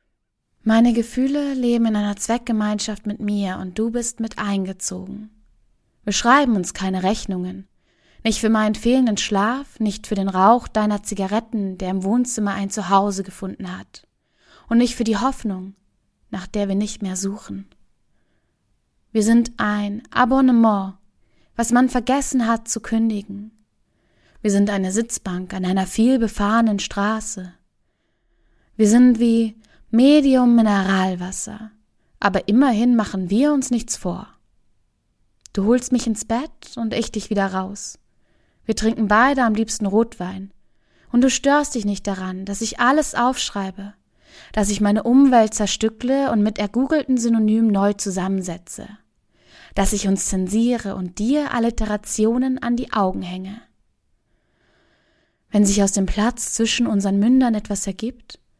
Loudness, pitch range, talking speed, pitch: -20 LUFS, 195-235 Hz, 140 wpm, 215 Hz